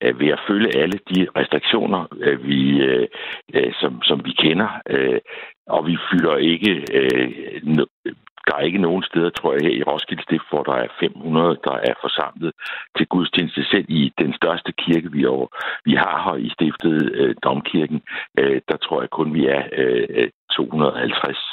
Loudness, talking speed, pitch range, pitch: -20 LUFS, 155 wpm, 70-110 Hz, 85 Hz